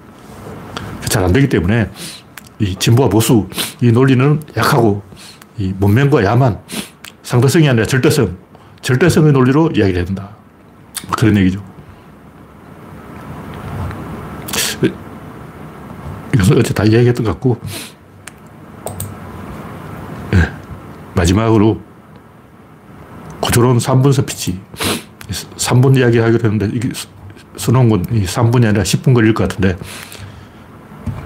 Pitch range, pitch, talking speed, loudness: 100-125 Hz, 110 Hz, 205 characters per minute, -14 LUFS